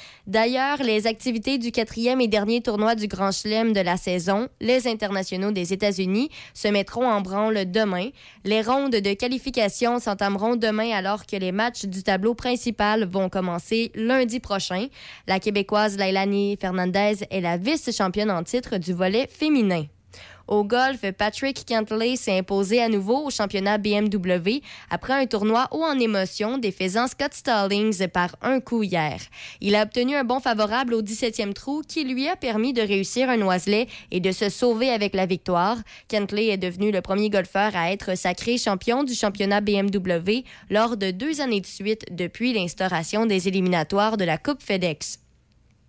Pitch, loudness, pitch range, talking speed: 210 Hz, -23 LUFS, 195-240 Hz, 165 wpm